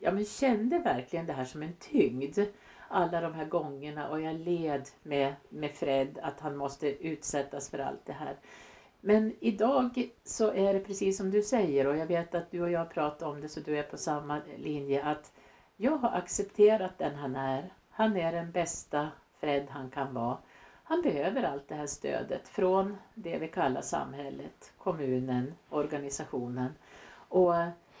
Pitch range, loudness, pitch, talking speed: 140-195 Hz, -32 LUFS, 160 Hz, 175 wpm